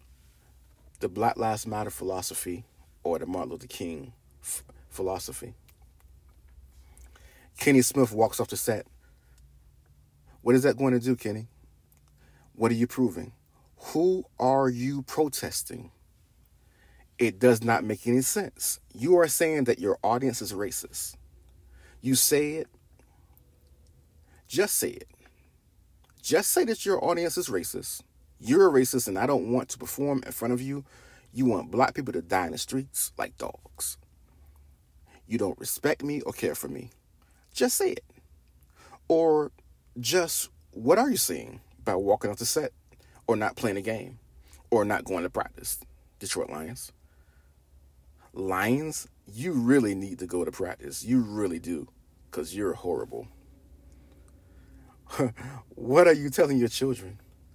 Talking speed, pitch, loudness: 145 wpm, 95 Hz, -27 LUFS